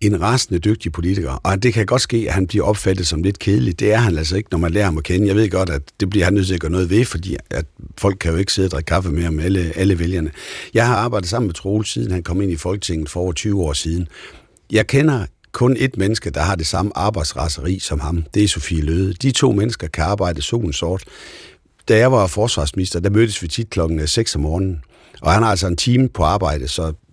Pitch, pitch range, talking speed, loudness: 95 Hz, 85-105 Hz, 255 wpm, -18 LUFS